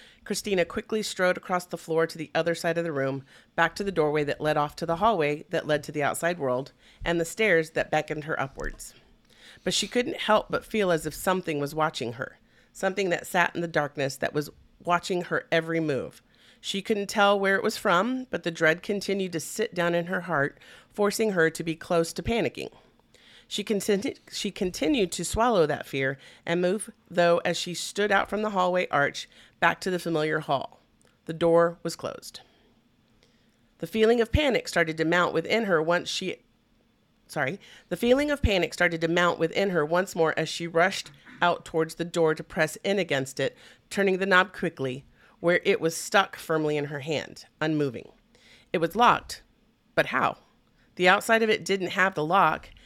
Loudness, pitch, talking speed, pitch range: -26 LUFS, 170 Hz, 195 wpm, 160-195 Hz